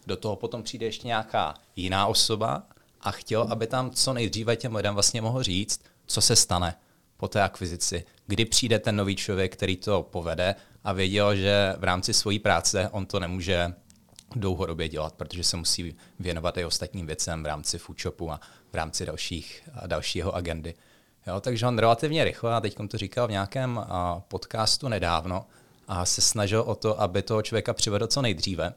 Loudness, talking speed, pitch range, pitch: -27 LUFS, 175 wpm, 90-115 Hz, 100 Hz